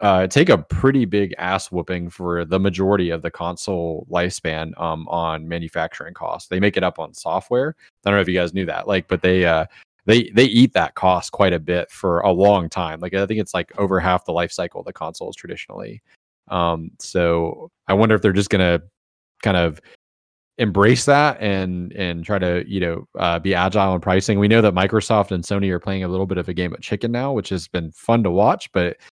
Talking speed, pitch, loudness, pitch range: 225 wpm, 90 Hz, -19 LUFS, 85-100 Hz